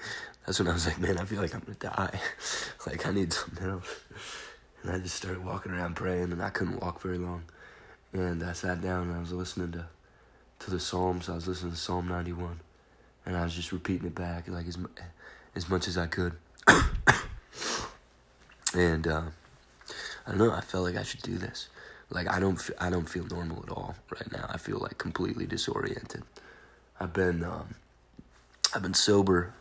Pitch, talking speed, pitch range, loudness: 90 Hz, 195 wpm, 85-95 Hz, -31 LUFS